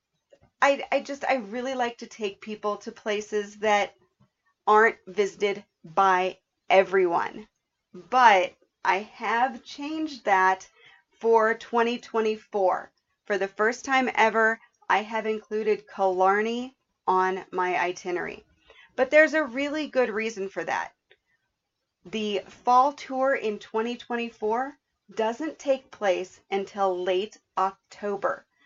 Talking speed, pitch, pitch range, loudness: 115 wpm, 215 Hz, 195-245 Hz, -26 LUFS